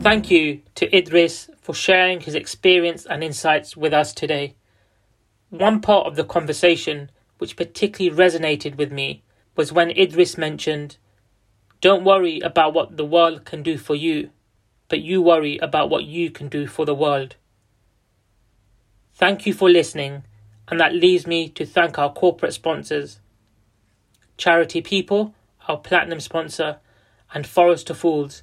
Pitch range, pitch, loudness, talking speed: 125-170 Hz, 155 Hz, -19 LUFS, 145 wpm